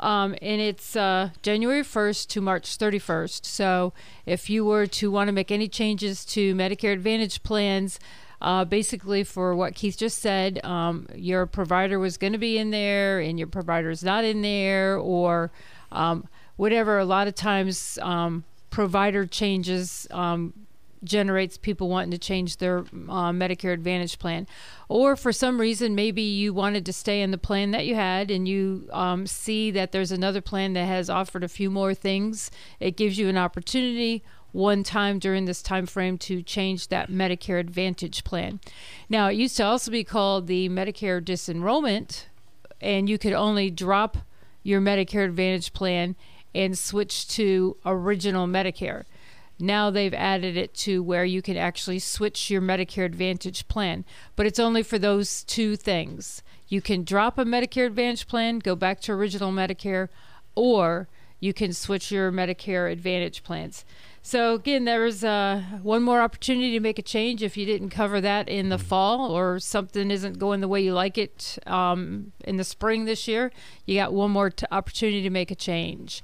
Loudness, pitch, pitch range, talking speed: -25 LUFS, 195 Hz, 185-210 Hz, 175 wpm